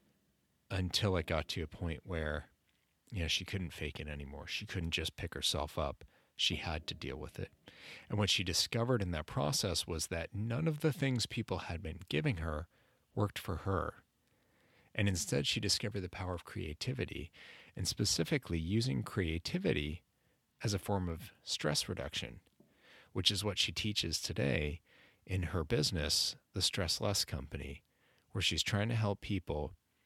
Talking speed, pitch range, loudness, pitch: 170 wpm, 80-105 Hz, -36 LUFS, 95 Hz